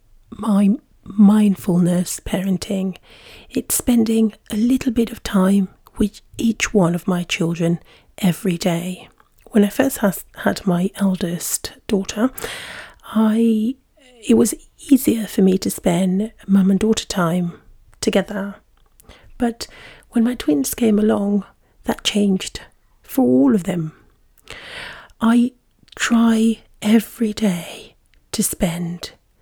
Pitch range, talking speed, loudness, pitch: 190-230 Hz, 115 wpm, -19 LUFS, 210 Hz